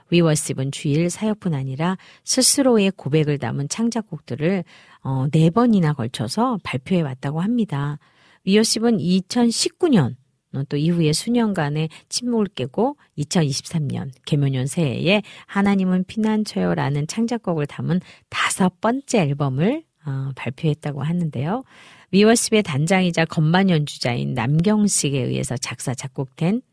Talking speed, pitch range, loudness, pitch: 300 characters per minute, 140-210 Hz, -21 LUFS, 165 Hz